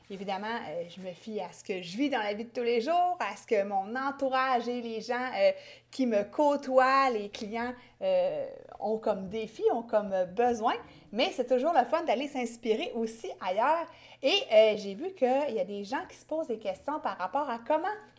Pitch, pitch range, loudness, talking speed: 245 Hz, 210-280 Hz, -30 LUFS, 200 wpm